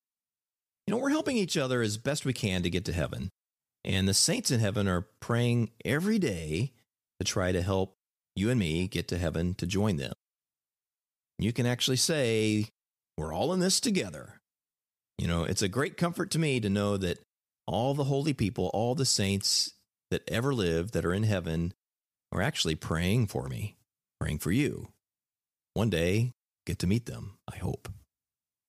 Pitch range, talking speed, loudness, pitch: 90-130 Hz, 180 wpm, -30 LUFS, 105 Hz